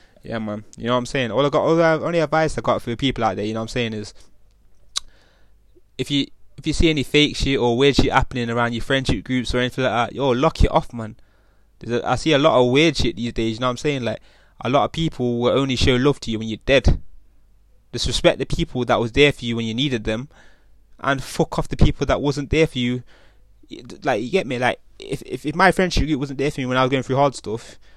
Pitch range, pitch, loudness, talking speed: 115-145 Hz, 125 Hz, -20 LUFS, 270 wpm